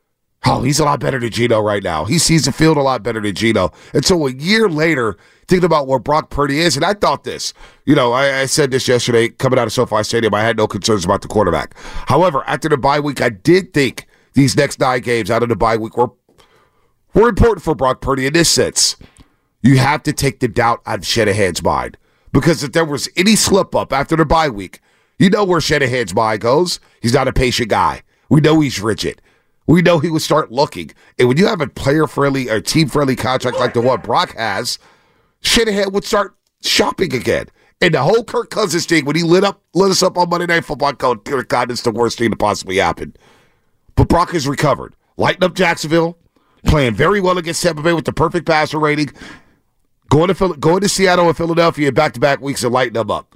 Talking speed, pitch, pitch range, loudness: 225 wpm, 145 Hz, 125-165 Hz, -15 LUFS